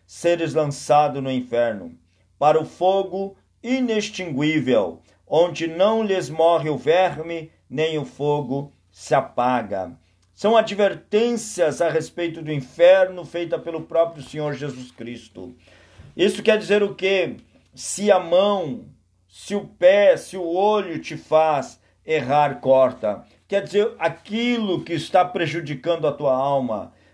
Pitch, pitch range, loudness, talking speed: 160 Hz, 135-190 Hz, -21 LUFS, 130 wpm